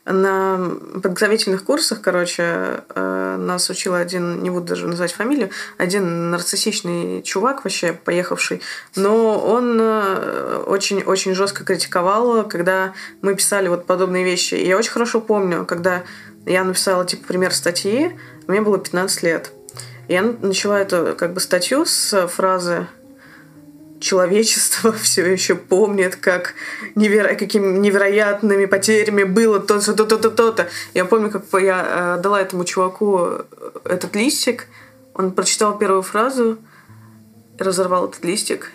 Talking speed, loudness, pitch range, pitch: 125 wpm, -18 LUFS, 180-215 Hz, 190 Hz